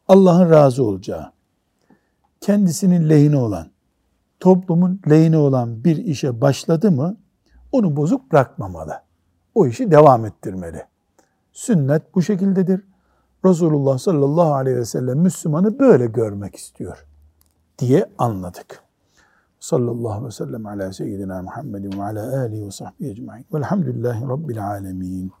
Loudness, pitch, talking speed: -18 LUFS, 135 Hz, 120 wpm